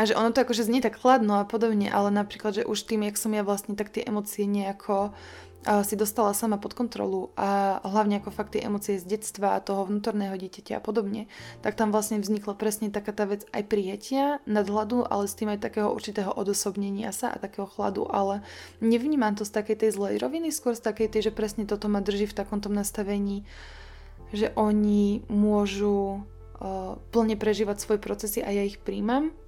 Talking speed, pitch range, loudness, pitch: 195 wpm, 200-220 Hz, -27 LUFS, 210 Hz